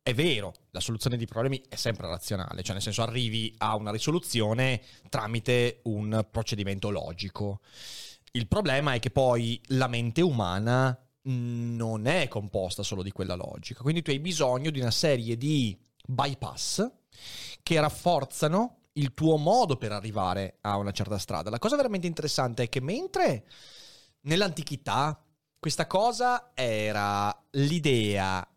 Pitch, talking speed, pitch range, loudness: 120 Hz, 140 wpm, 105-145 Hz, -29 LUFS